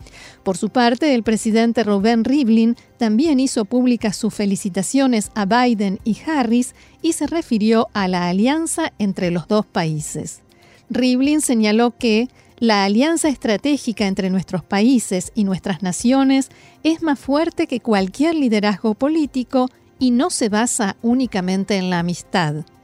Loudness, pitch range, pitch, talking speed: -18 LUFS, 200-260 Hz, 230 Hz, 140 wpm